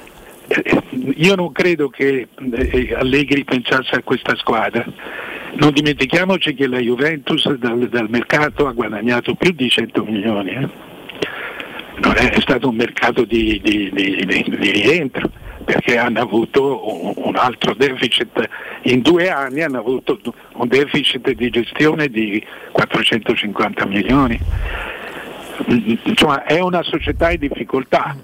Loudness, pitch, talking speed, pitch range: -17 LUFS, 135 Hz, 120 wpm, 120-150 Hz